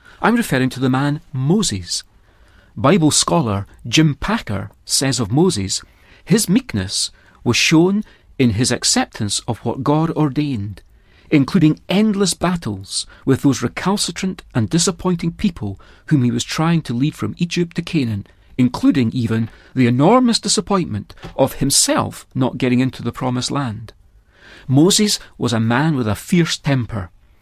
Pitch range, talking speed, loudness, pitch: 110-170 Hz, 140 wpm, -17 LUFS, 135 Hz